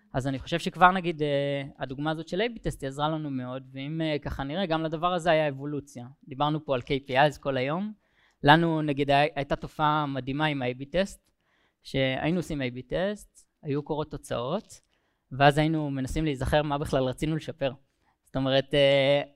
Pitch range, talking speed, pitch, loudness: 135-160 Hz, 170 wpm, 145 Hz, -27 LUFS